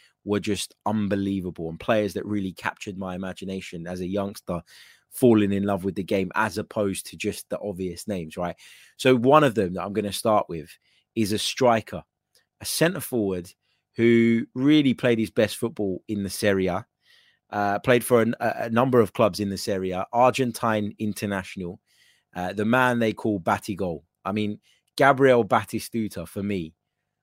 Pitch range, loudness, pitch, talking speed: 95-115 Hz, -24 LUFS, 105 Hz, 170 wpm